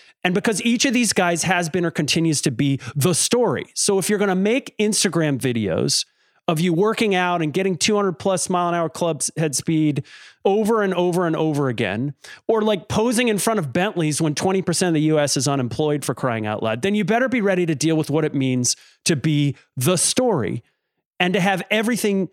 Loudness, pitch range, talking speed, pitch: -20 LUFS, 150-205 Hz, 210 wpm, 175 Hz